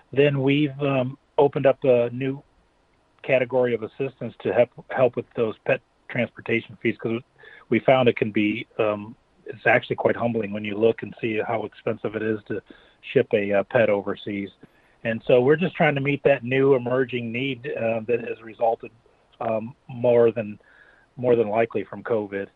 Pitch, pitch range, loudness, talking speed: 120 Hz, 110-135 Hz, -23 LUFS, 180 wpm